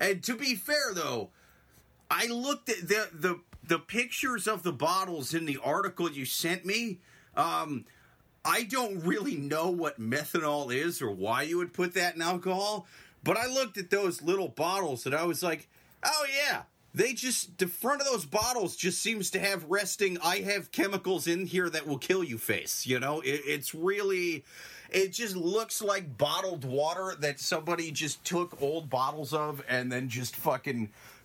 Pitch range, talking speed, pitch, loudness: 150-205 Hz, 180 wpm, 180 Hz, -31 LUFS